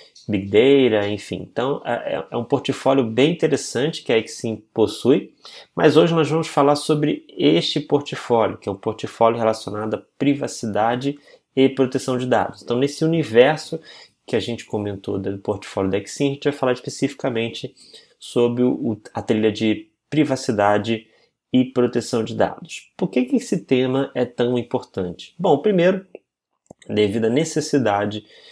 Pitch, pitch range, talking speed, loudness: 125 Hz, 110-140 Hz, 145 wpm, -20 LUFS